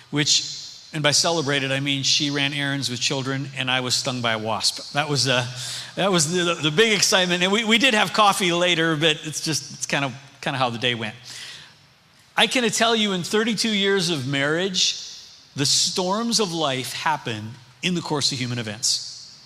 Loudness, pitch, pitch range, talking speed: -21 LUFS, 145 Hz, 130-180 Hz, 205 wpm